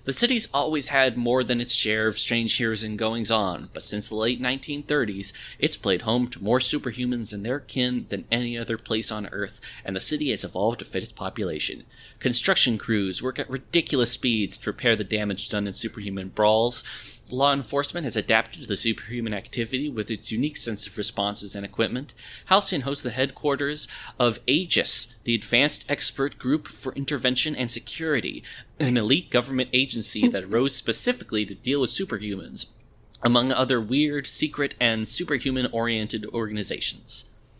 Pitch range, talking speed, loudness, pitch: 110-135 Hz, 170 wpm, -25 LUFS, 120 Hz